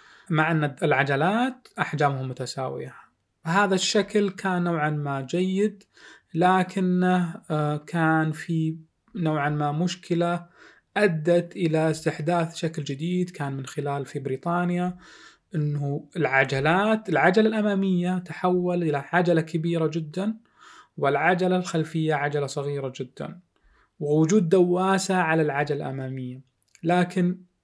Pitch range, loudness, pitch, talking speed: 150-180 Hz, -25 LUFS, 165 Hz, 100 wpm